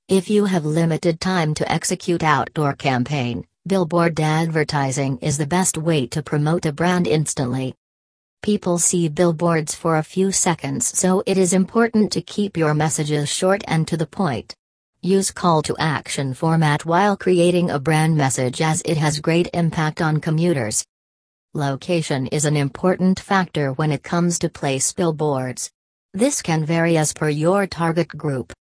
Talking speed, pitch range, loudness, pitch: 160 wpm, 150-175 Hz, -20 LUFS, 160 Hz